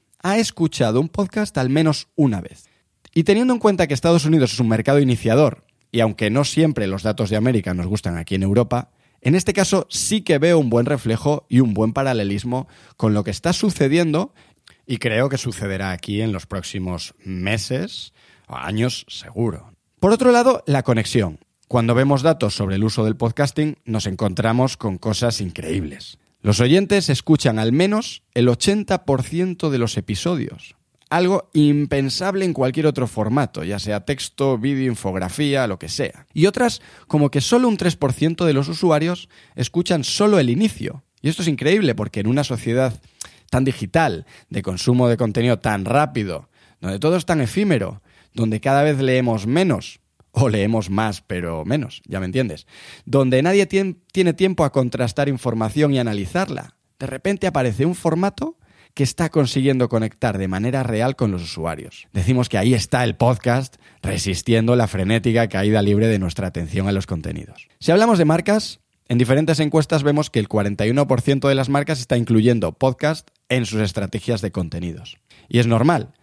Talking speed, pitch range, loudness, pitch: 170 wpm, 110-155 Hz, -19 LUFS, 125 Hz